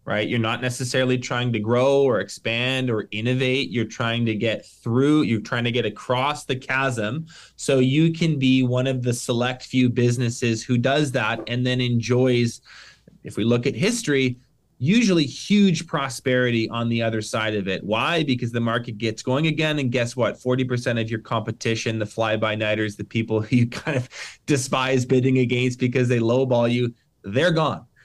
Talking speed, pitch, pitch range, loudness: 180 wpm, 125 Hz, 115-130 Hz, -22 LUFS